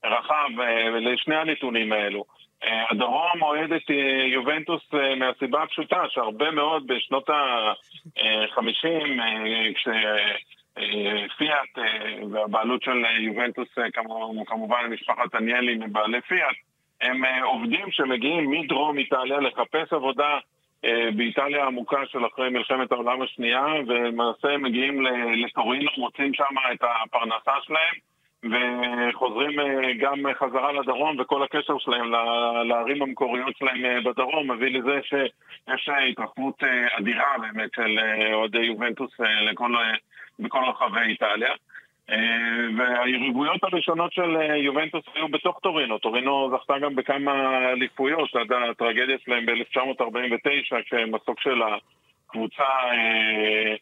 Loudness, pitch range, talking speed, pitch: -24 LUFS, 115-140 Hz, 100 wpm, 125 Hz